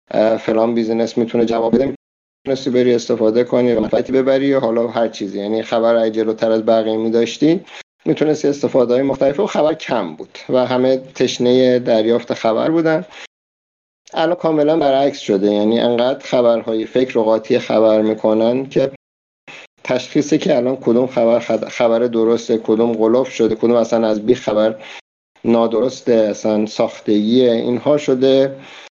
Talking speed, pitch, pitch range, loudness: 145 wpm, 120 Hz, 110-130 Hz, -16 LUFS